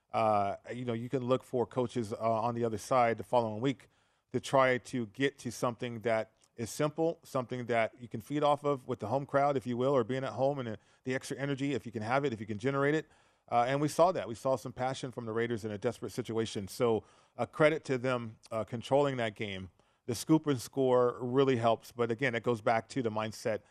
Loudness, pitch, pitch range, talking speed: -32 LUFS, 125 Hz, 115-135 Hz, 245 wpm